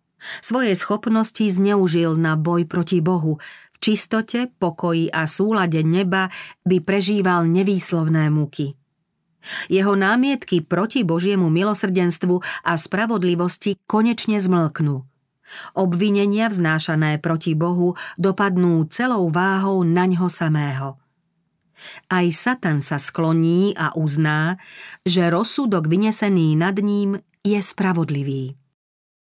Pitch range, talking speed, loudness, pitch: 165-200 Hz, 100 wpm, -20 LUFS, 180 Hz